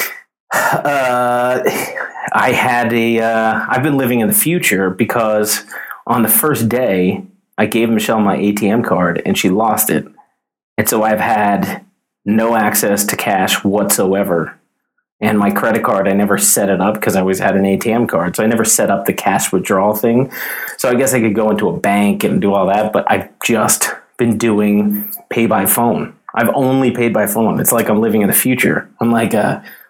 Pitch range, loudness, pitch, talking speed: 105-125 Hz, -14 LUFS, 115 Hz, 195 wpm